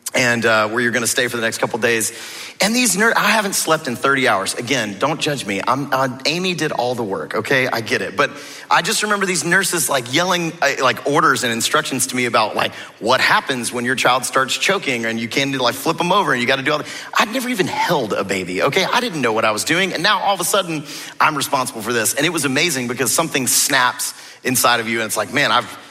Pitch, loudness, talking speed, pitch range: 135 Hz, -17 LUFS, 260 wpm, 120-175 Hz